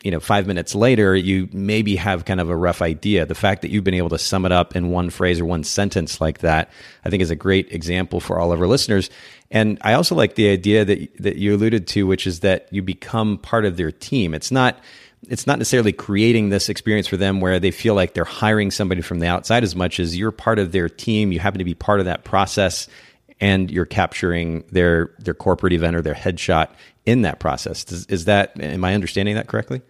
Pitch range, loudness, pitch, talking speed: 90-105 Hz, -19 LUFS, 95 Hz, 240 wpm